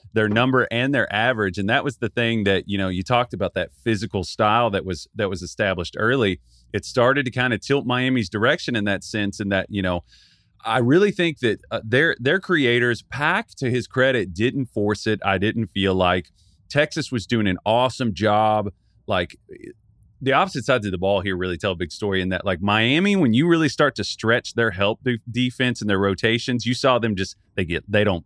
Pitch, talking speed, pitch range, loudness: 110 Hz, 215 wpm, 100-125 Hz, -21 LUFS